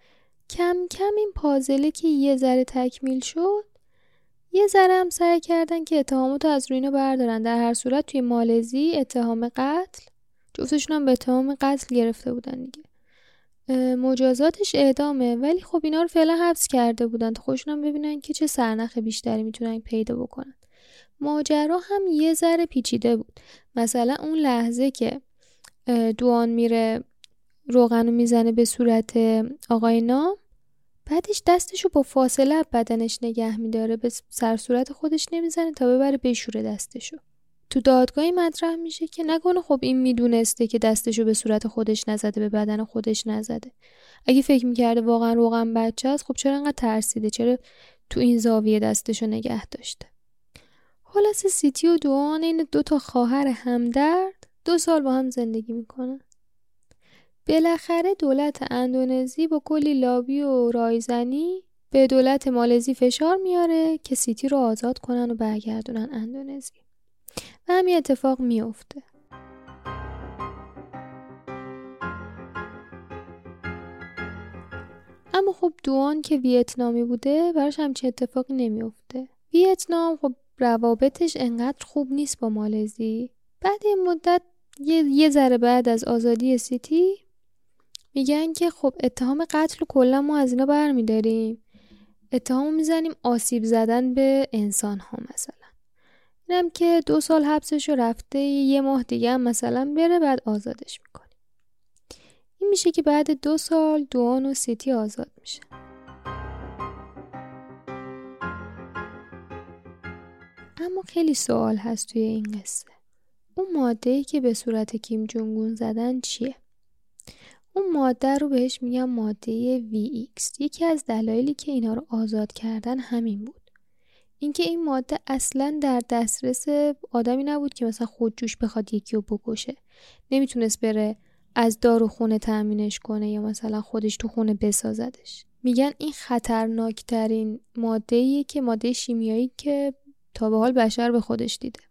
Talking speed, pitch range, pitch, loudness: 135 wpm, 225-290 Hz, 250 Hz, -23 LUFS